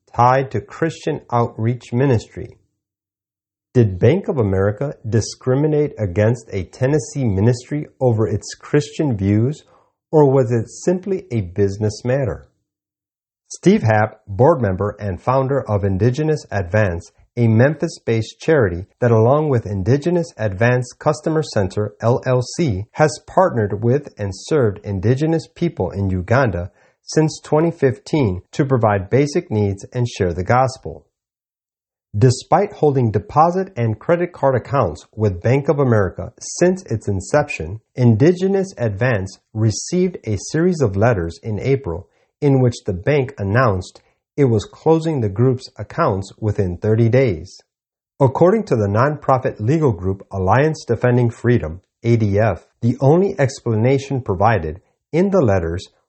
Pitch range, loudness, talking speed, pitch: 105-140 Hz, -18 LUFS, 125 wpm, 120 Hz